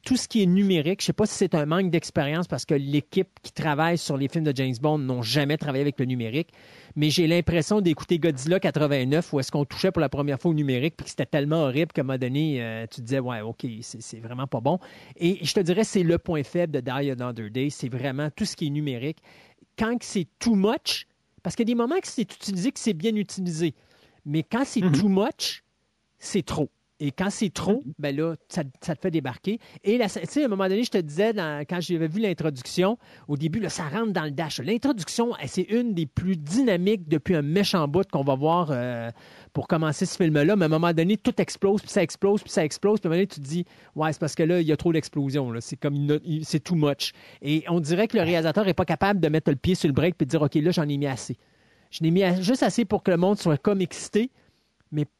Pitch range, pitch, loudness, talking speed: 145-195 Hz, 165 Hz, -25 LUFS, 260 wpm